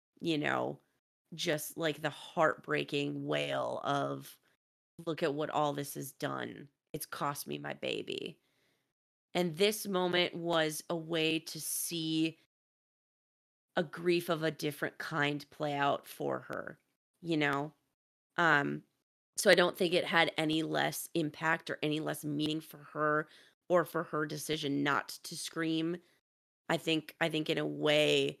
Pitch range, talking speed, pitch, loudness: 145-165 Hz, 150 wpm, 155 Hz, -33 LUFS